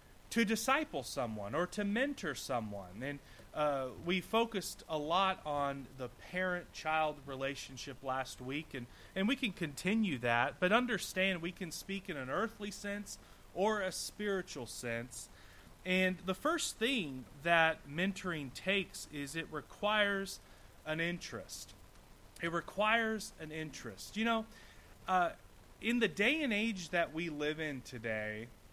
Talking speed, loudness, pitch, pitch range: 140 wpm, -36 LUFS, 170 Hz, 135-200 Hz